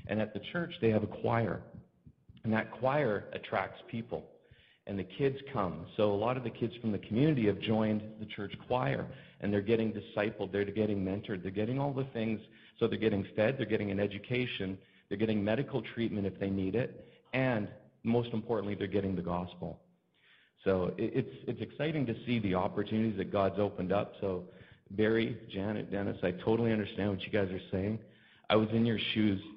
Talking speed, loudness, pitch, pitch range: 195 wpm, -34 LUFS, 105 Hz, 100-115 Hz